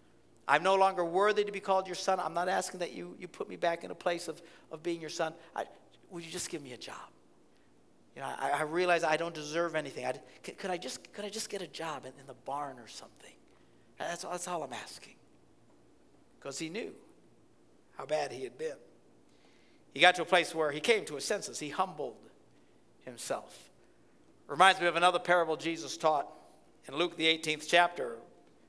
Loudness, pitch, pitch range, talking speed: -32 LUFS, 170 Hz, 155-185 Hz, 205 wpm